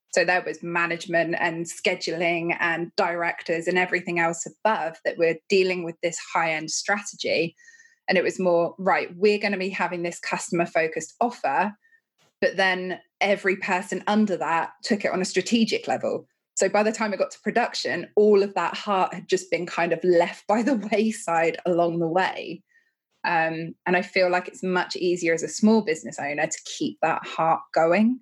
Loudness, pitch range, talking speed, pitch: -24 LUFS, 170-205 Hz, 185 wpm, 180 Hz